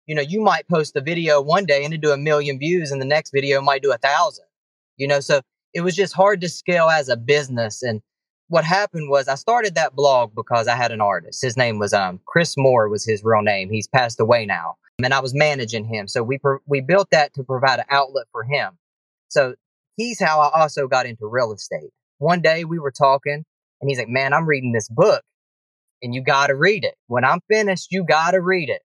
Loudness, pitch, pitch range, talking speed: -19 LUFS, 140 Hz, 125-165 Hz, 240 wpm